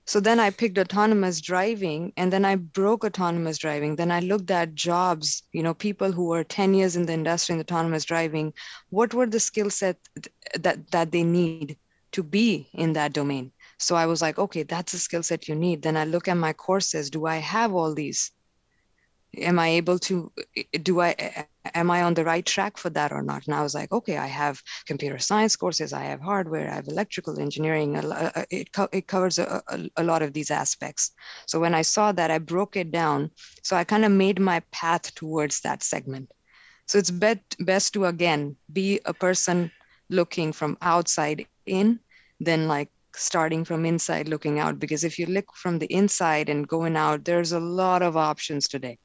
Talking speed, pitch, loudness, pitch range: 200 wpm, 170 Hz, -25 LUFS, 155-190 Hz